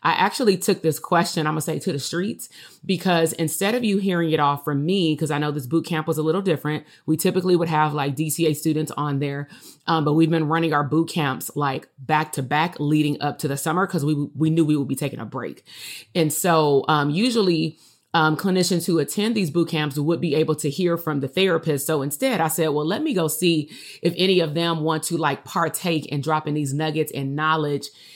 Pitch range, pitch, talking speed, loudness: 150-170 Hz, 155 Hz, 235 wpm, -22 LUFS